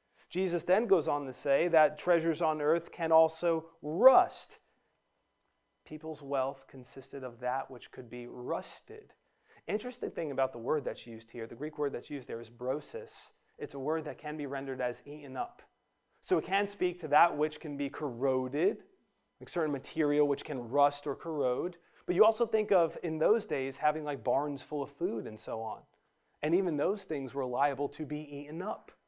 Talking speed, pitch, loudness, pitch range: 190 wpm, 150 Hz, -32 LUFS, 135-170 Hz